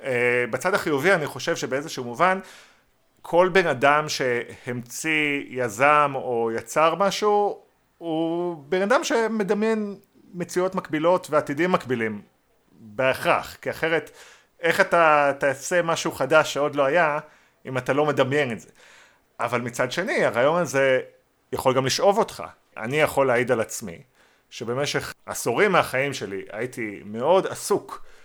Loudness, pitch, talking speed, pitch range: -23 LUFS, 150 Hz, 130 wpm, 130-180 Hz